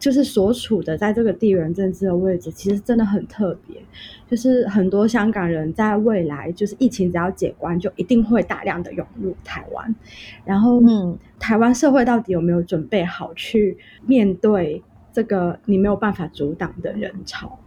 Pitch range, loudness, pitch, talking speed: 180-225 Hz, -20 LUFS, 200 Hz, 275 characters per minute